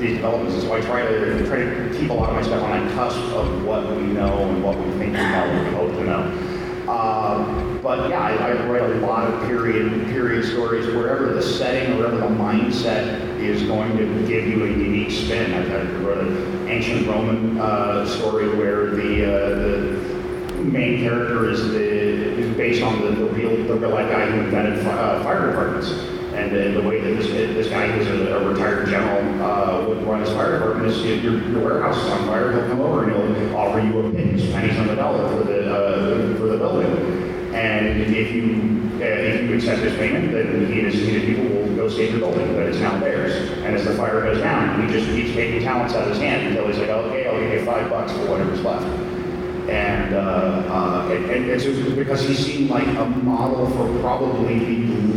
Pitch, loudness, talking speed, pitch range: 110 Hz, -20 LUFS, 215 wpm, 105-120 Hz